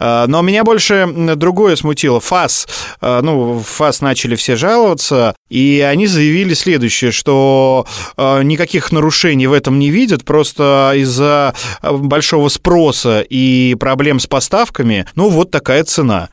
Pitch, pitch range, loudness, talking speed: 140 Hz, 125-160 Hz, -11 LUFS, 125 wpm